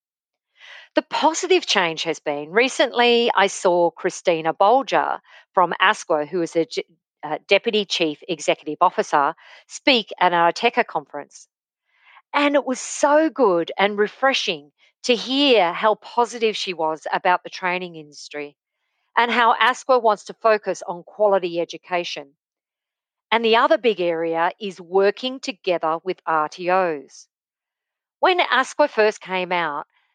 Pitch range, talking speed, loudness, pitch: 170-235 Hz, 135 wpm, -20 LUFS, 190 Hz